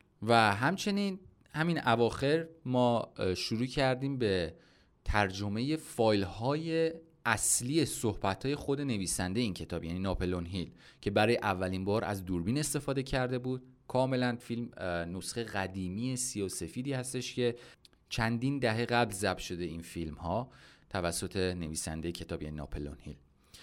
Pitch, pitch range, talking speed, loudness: 110 Hz, 90-130 Hz, 135 wpm, -33 LUFS